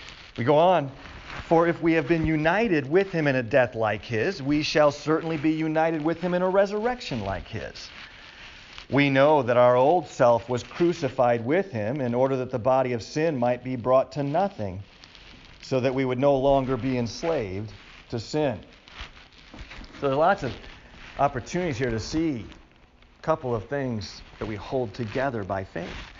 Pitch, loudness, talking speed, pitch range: 130 Hz, -24 LUFS, 180 wpm, 115-160 Hz